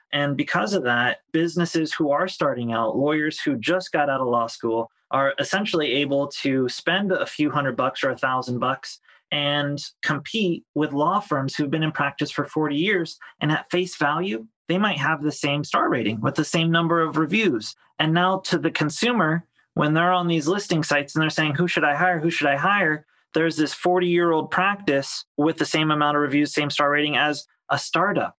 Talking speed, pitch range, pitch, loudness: 210 wpm, 145-170 Hz, 155 Hz, -22 LUFS